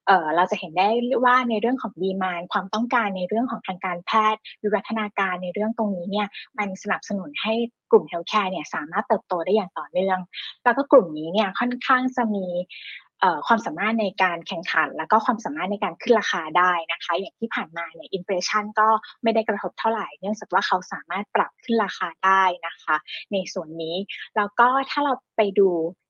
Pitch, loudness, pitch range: 205 Hz, -23 LUFS, 180-225 Hz